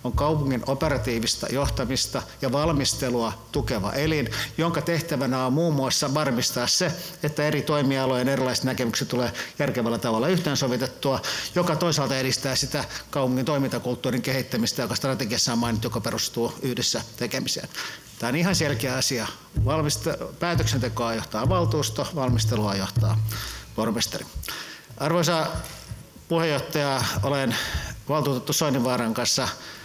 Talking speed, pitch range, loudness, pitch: 115 wpm, 115-145 Hz, -25 LUFS, 130 Hz